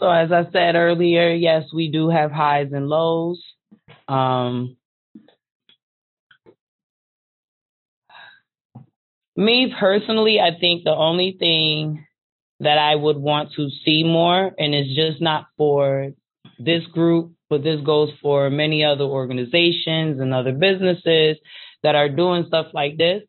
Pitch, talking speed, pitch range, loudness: 160 Hz, 130 wpm, 150-170 Hz, -18 LUFS